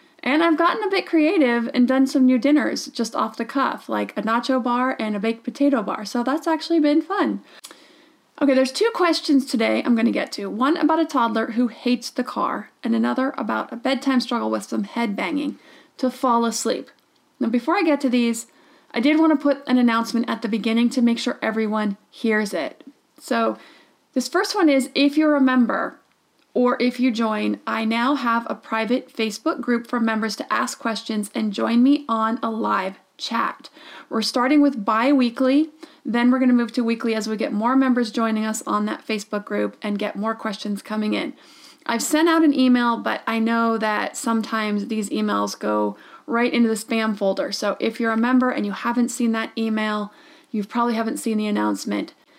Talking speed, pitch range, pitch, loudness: 200 wpm, 225-280 Hz, 245 Hz, -21 LUFS